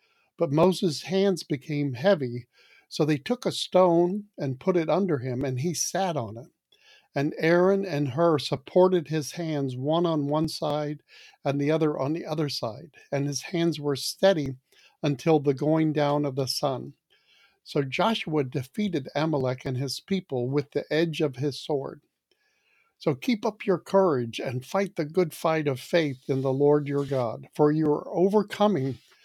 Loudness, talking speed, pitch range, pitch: -26 LUFS, 170 wpm, 140-180 Hz, 150 Hz